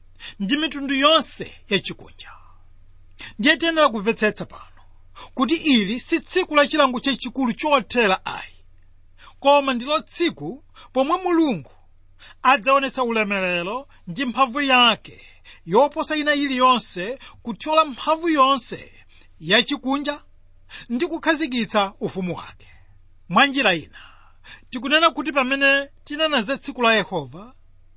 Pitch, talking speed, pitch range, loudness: 255 Hz, 100 wpm, 175-285 Hz, -20 LUFS